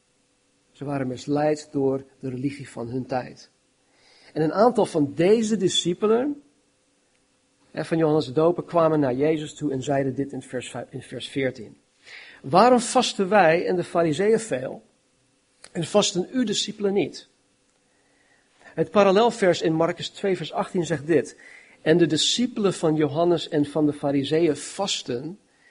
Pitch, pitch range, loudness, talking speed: 160 Hz, 140-195 Hz, -23 LUFS, 140 wpm